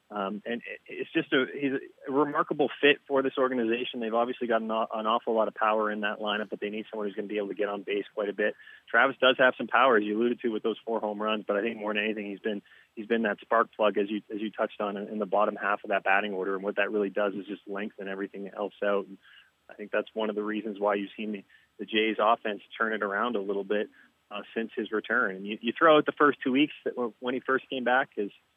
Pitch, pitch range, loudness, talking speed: 110 Hz, 105-120 Hz, -28 LUFS, 270 wpm